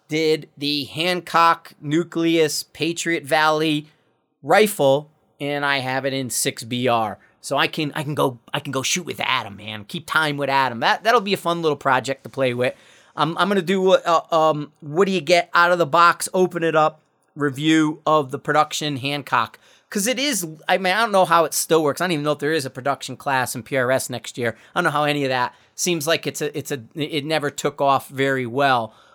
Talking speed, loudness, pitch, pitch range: 220 wpm, -20 LUFS, 150 Hz, 135-165 Hz